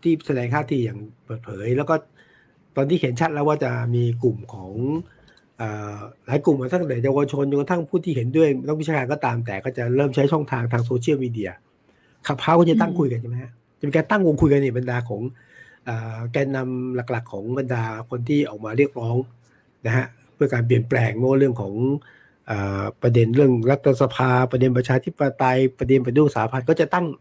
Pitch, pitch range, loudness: 130 Hz, 120-145 Hz, -22 LUFS